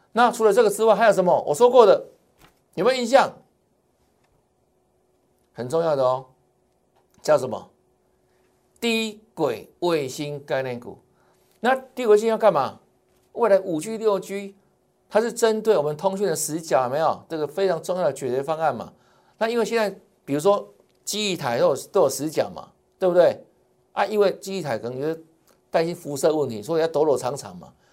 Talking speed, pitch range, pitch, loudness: 250 characters per minute, 160-220 Hz, 195 Hz, -22 LUFS